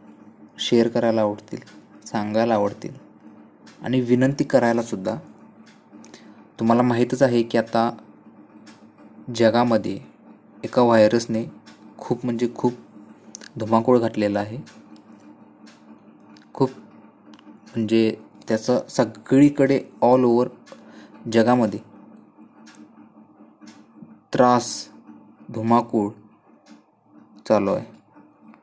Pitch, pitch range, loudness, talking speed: 115 Hz, 105-120 Hz, -21 LUFS, 70 wpm